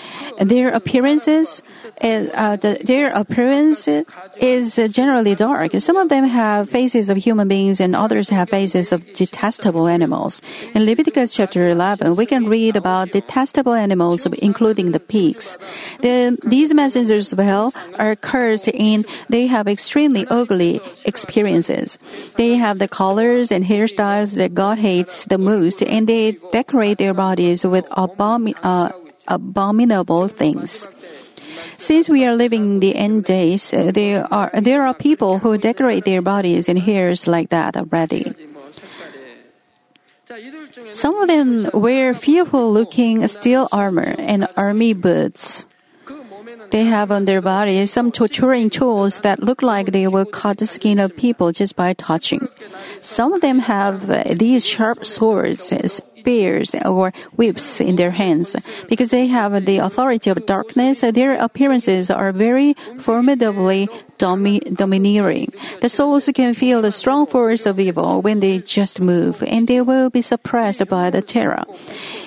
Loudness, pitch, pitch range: -16 LUFS, 215 Hz, 195-245 Hz